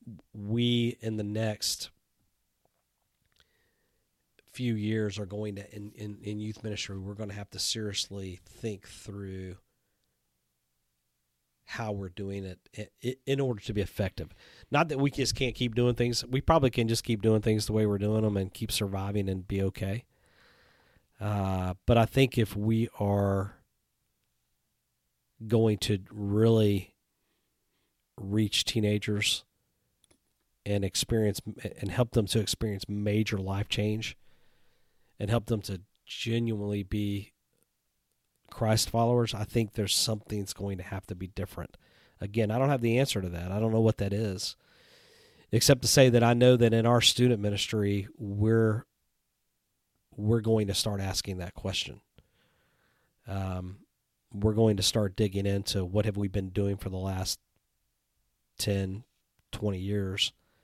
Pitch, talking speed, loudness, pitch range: 105 Hz, 145 wpm, -29 LUFS, 95-110 Hz